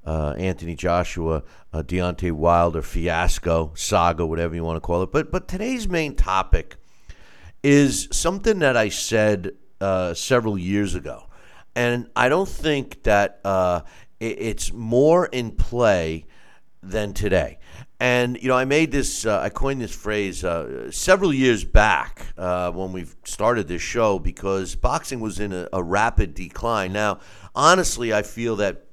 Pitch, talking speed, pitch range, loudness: 95 Hz, 155 wpm, 90-120 Hz, -22 LUFS